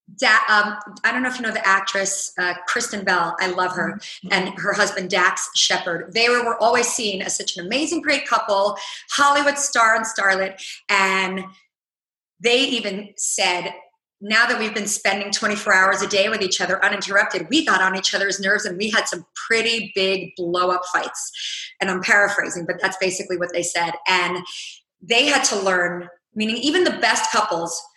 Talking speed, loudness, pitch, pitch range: 185 wpm, -19 LUFS, 200 Hz, 185-225 Hz